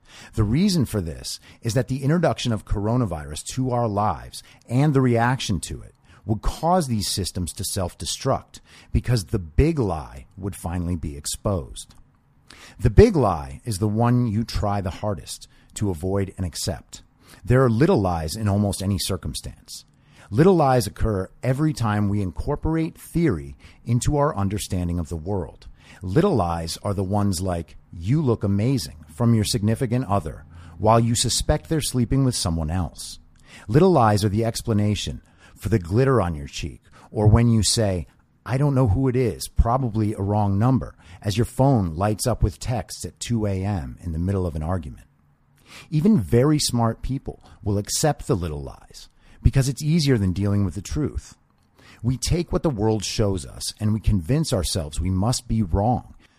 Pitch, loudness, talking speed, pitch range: 105 Hz, -23 LUFS, 175 wpm, 90-125 Hz